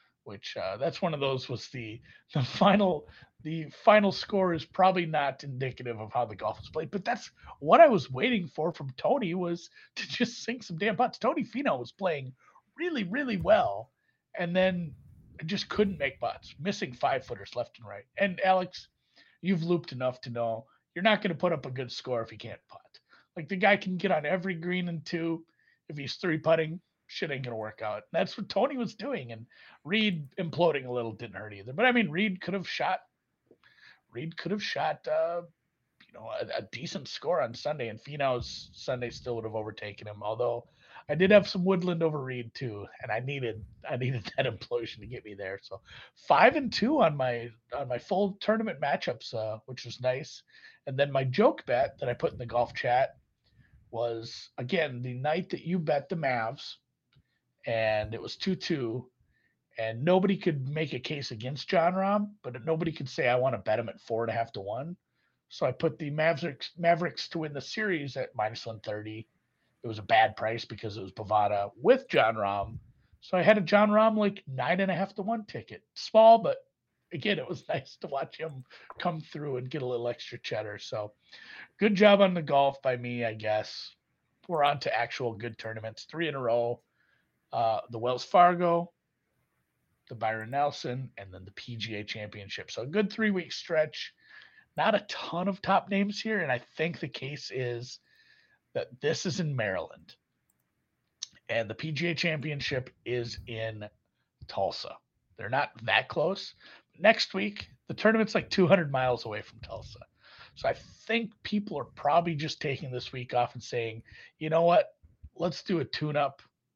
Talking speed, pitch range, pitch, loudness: 195 wpm, 120-185 Hz, 145 Hz, -29 LUFS